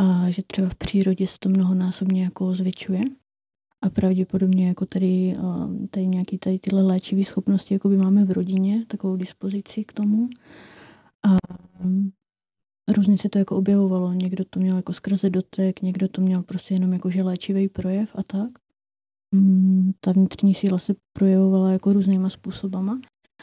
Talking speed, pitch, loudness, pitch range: 150 wpm, 190 Hz, -22 LUFS, 185-200 Hz